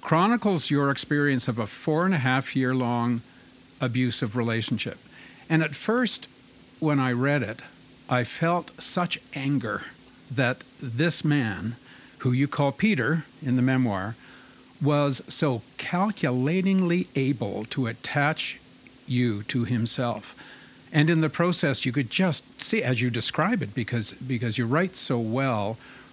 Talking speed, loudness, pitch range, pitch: 140 wpm, -26 LUFS, 120-155 Hz, 135 Hz